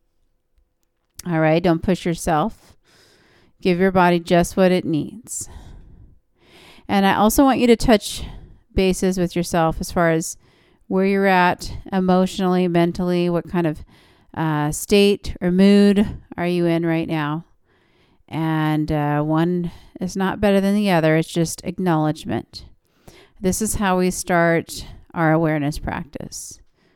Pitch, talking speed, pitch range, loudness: 175 Hz, 140 wpm, 160-190 Hz, -19 LUFS